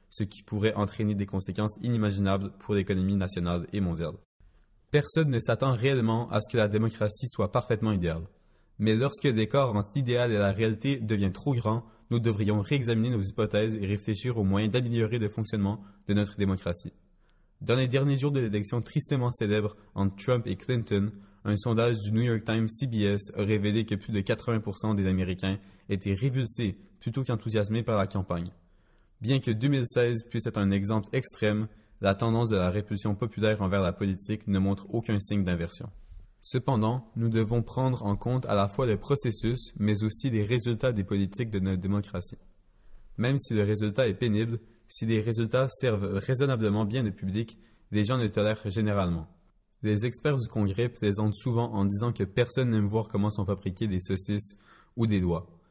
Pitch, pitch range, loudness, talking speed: 105 Hz, 100-120 Hz, -29 LUFS, 180 wpm